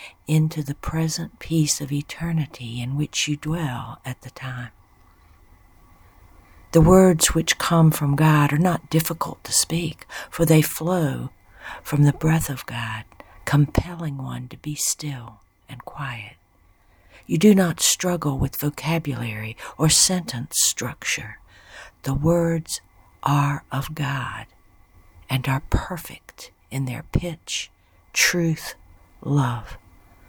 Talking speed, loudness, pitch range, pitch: 120 wpm, -22 LUFS, 105-160 Hz, 135 Hz